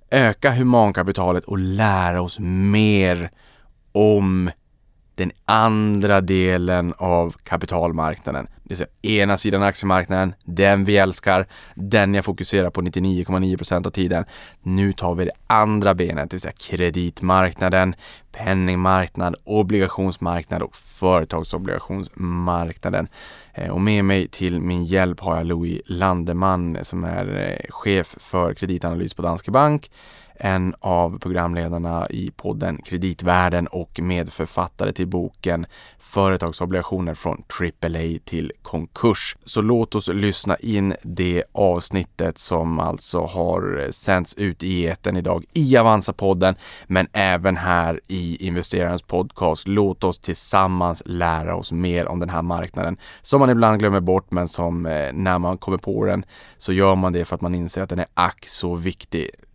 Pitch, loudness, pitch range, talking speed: 90 Hz, -21 LUFS, 85-95 Hz, 135 wpm